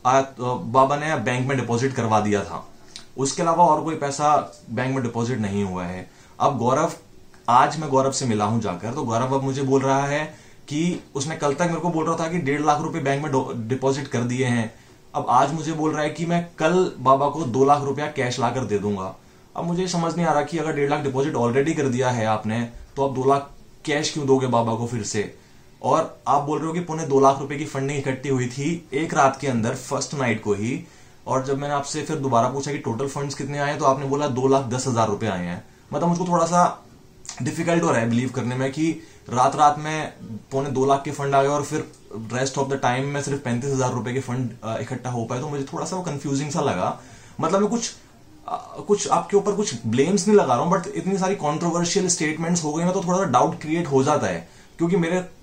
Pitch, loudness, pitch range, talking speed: 140 Hz, -23 LUFS, 125-155 Hz, 235 wpm